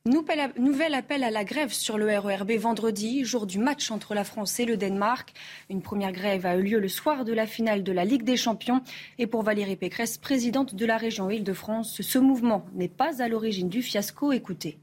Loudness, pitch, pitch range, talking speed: -27 LUFS, 225 Hz, 200-250 Hz, 210 wpm